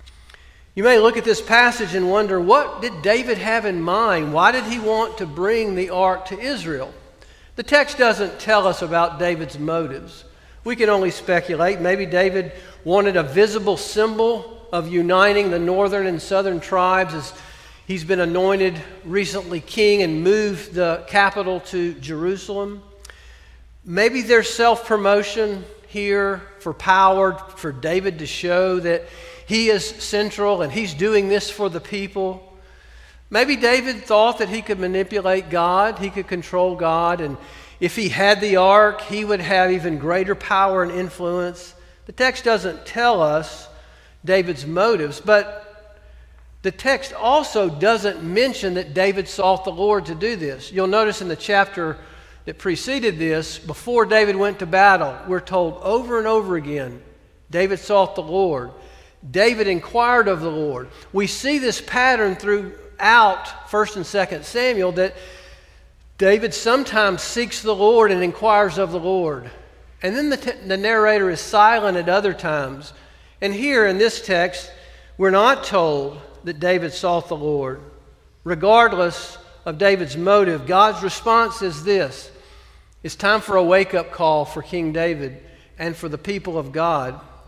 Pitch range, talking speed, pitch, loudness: 170-210 Hz, 155 wpm, 190 Hz, -19 LUFS